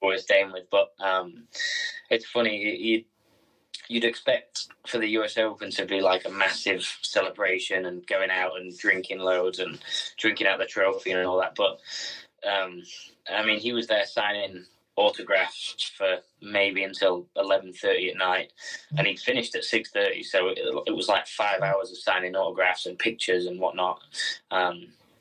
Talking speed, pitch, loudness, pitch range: 170 wpm, 100 Hz, -26 LUFS, 95-115 Hz